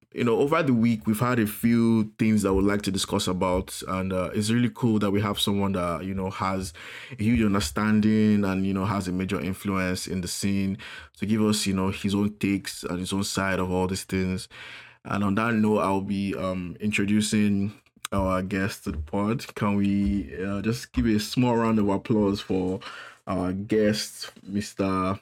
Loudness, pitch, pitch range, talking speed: -25 LUFS, 100 Hz, 95-105 Hz, 205 wpm